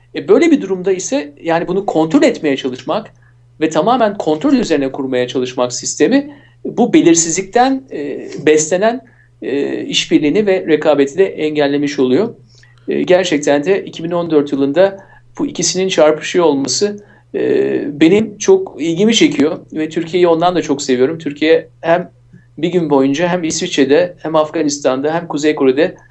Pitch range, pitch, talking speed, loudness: 145-200 Hz, 165 Hz, 125 wpm, -14 LUFS